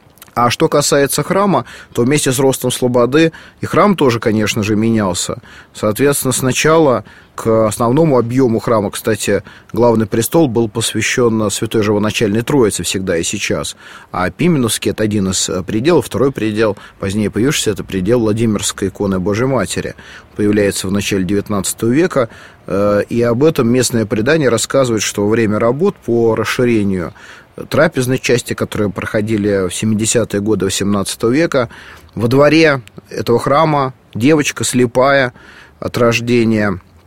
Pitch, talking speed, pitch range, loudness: 115 Hz, 135 wpm, 105-125 Hz, -14 LUFS